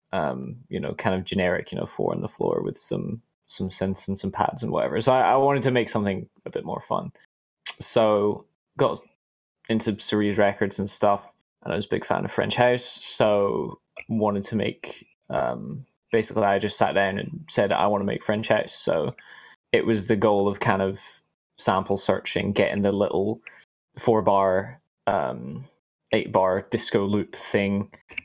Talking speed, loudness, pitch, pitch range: 180 wpm, -23 LUFS, 100 Hz, 100-110 Hz